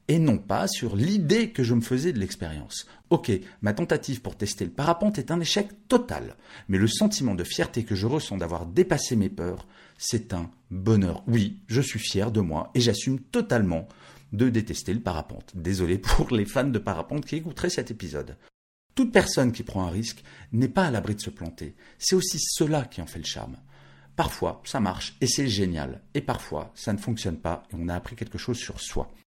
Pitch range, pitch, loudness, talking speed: 95-140 Hz, 115 Hz, -27 LUFS, 205 wpm